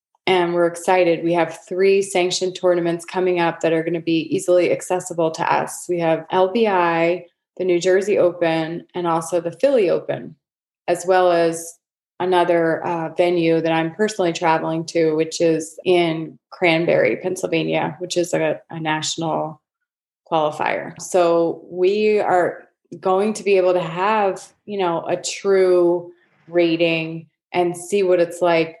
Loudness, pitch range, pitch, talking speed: -19 LUFS, 165-185 Hz, 175 Hz, 150 wpm